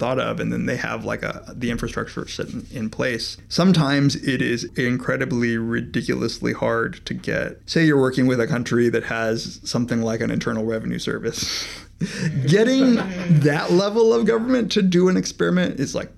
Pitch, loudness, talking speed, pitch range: 130 Hz, -21 LUFS, 175 wpm, 115-180 Hz